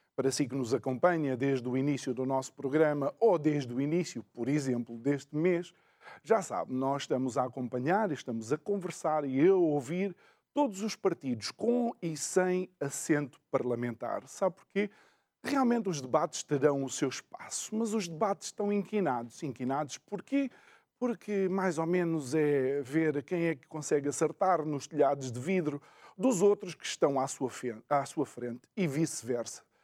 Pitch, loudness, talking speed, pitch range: 155 Hz, -32 LUFS, 160 wpm, 135-190 Hz